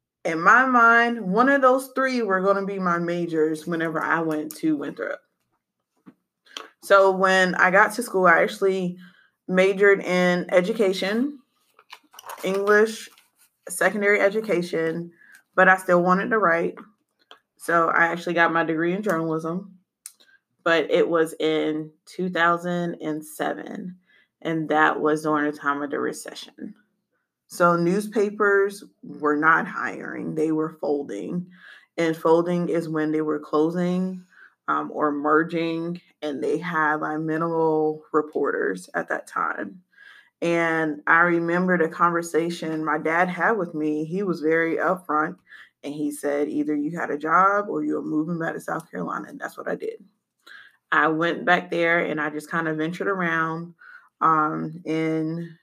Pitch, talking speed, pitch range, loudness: 170 Hz, 145 wpm, 155-190 Hz, -22 LUFS